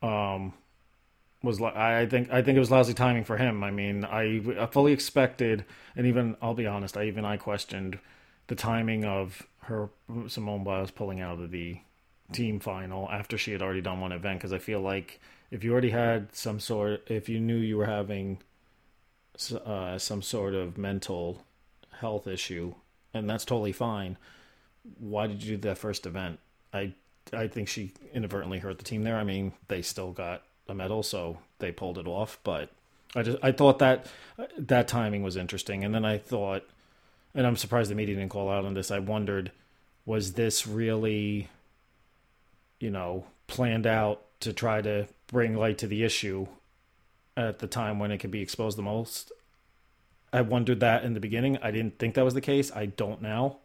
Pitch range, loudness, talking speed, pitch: 95-115 Hz, -30 LUFS, 185 wpm, 105 Hz